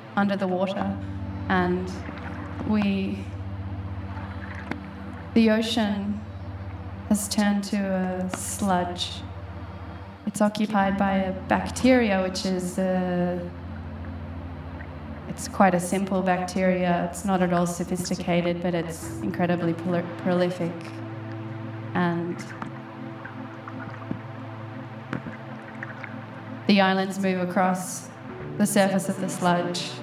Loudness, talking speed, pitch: -26 LUFS, 90 wpm, 130 Hz